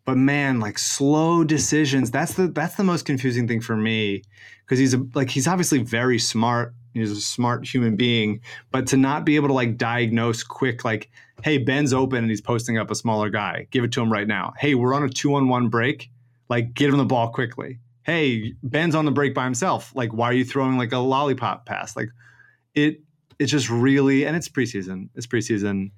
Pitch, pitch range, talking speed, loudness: 130 Hz, 115-140 Hz, 205 wpm, -22 LUFS